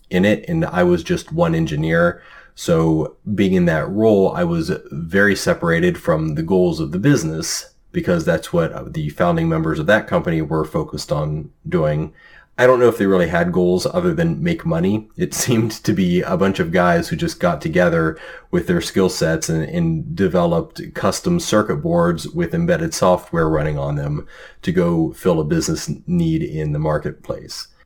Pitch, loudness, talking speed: 165 Hz, -18 LUFS, 185 wpm